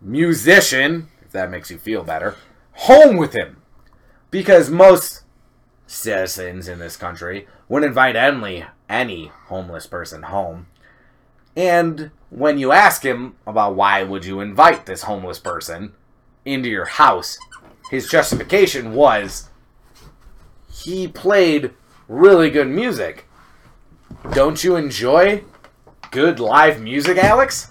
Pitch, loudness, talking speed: 135 Hz, -15 LUFS, 115 wpm